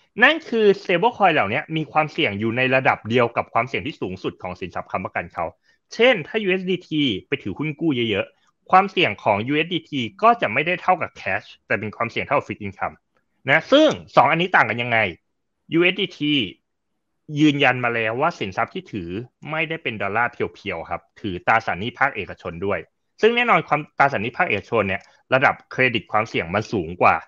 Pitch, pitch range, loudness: 150 Hz, 115-185 Hz, -21 LUFS